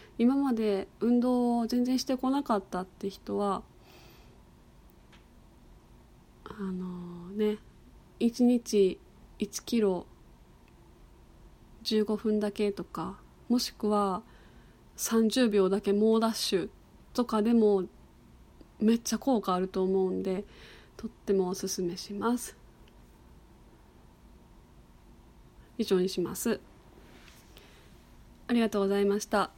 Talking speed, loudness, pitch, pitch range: 180 characters per minute, -29 LUFS, 210 Hz, 190-230 Hz